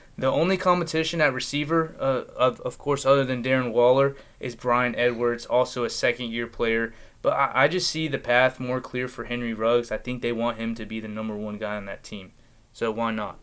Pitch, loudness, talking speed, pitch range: 125 Hz, -25 LUFS, 225 wpm, 115-135 Hz